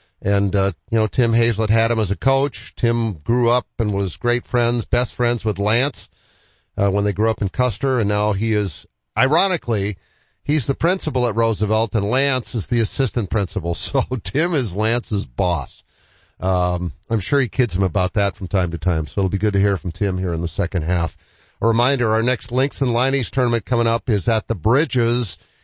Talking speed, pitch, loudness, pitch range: 210 wpm, 110 Hz, -20 LUFS, 100-120 Hz